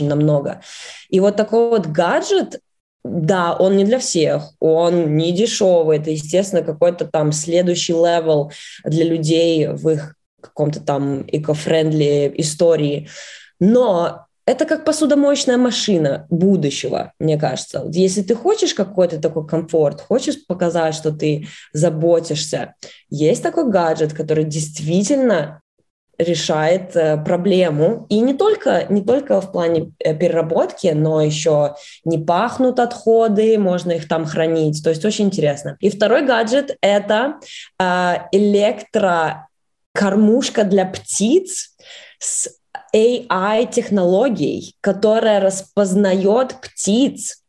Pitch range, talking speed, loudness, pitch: 160-220 Hz, 115 wpm, -17 LUFS, 180 Hz